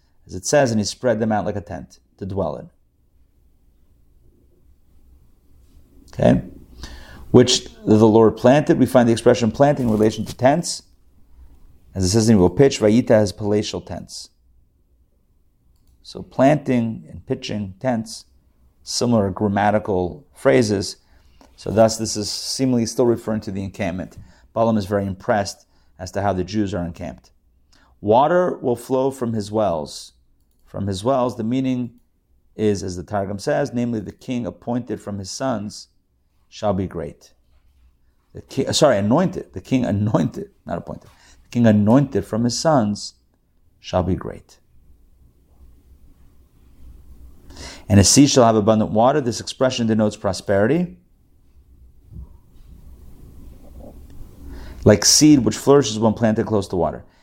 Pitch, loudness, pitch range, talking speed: 100 Hz, -19 LUFS, 70-115 Hz, 140 wpm